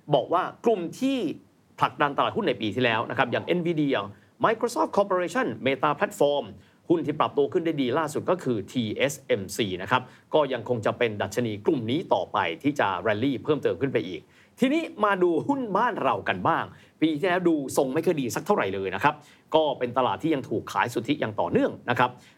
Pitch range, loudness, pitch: 125-185 Hz, -26 LUFS, 150 Hz